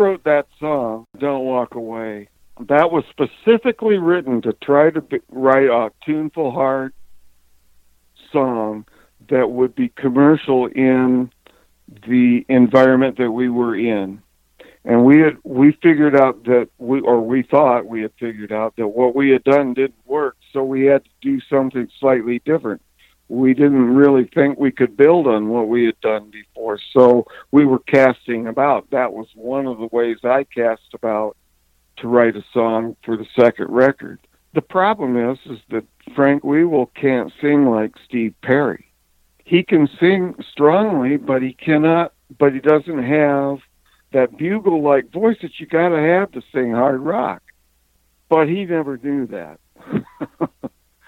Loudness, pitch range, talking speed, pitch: -17 LUFS, 115-145 Hz, 160 wpm, 130 Hz